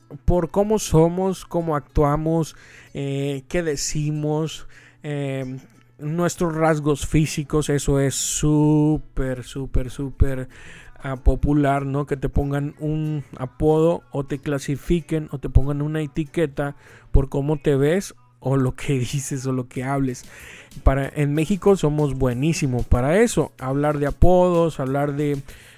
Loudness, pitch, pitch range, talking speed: -22 LUFS, 145 Hz, 135-155 Hz, 130 wpm